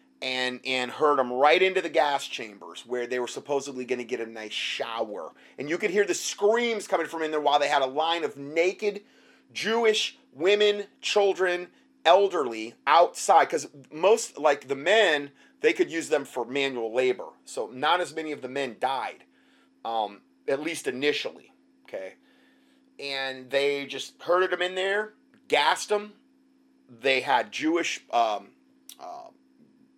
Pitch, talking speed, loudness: 170 Hz, 160 wpm, -26 LUFS